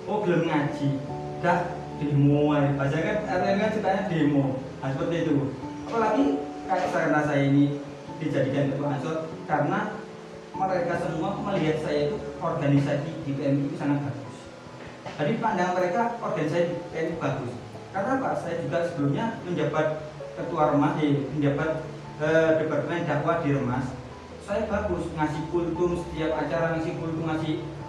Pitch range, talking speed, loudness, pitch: 145-170 Hz, 140 wpm, -26 LUFS, 155 Hz